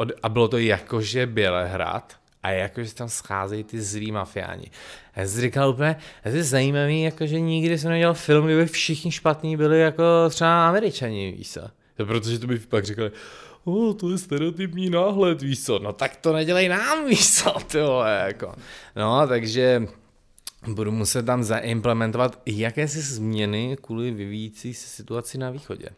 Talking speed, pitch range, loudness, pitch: 160 wpm, 110-160 Hz, -23 LUFS, 125 Hz